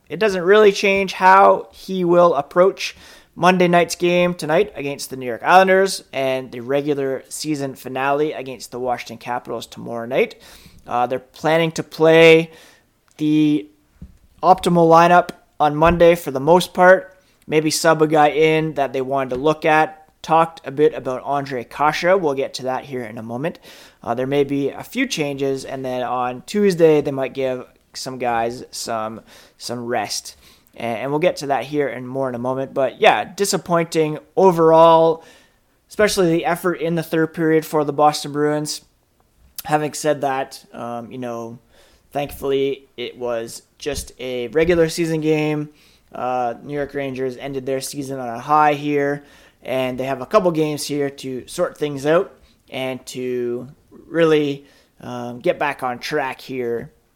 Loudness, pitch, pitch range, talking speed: -18 LUFS, 145 Hz, 130-165 Hz, 165 wpm